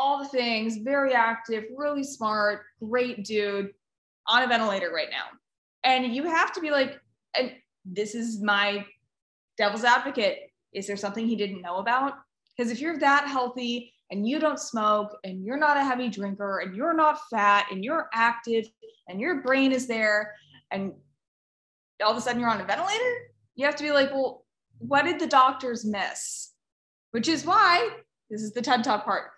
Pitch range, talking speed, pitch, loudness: 210-280 Hz, 180 wpm, 240 Hz, -26 LUFS